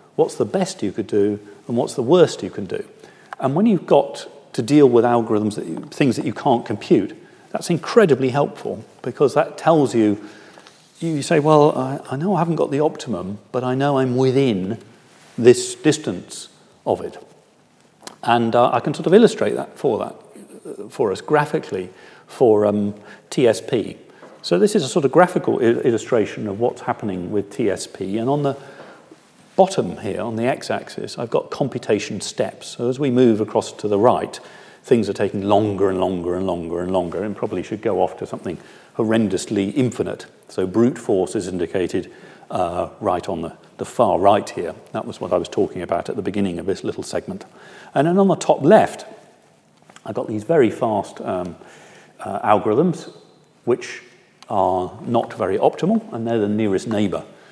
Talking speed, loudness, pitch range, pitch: 185 wpm, -20 LUFS, 105-145 Hz, 120 Hz